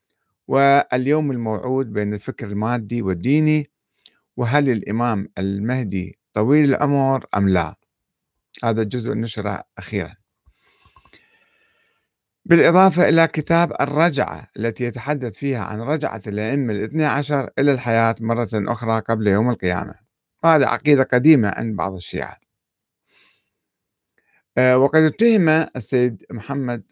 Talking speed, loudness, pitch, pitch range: 105 wpm, -19 LUFS, 120 Hz, 105-145 Hz